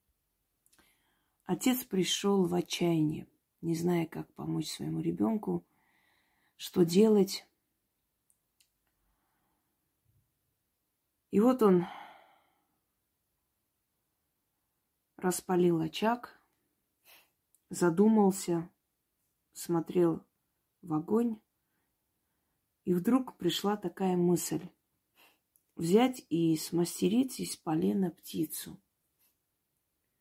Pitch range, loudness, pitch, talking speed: 170-205 Hz, -31 LUFS, 180 Hz, 65 wpm